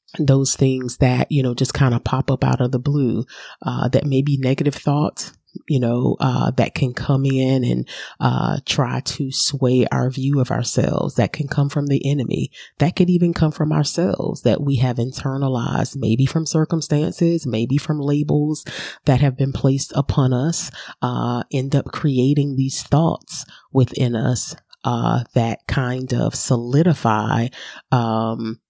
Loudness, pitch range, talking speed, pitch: -20 LUFS, 125-150 Hz, 165 wpm, 135 Hz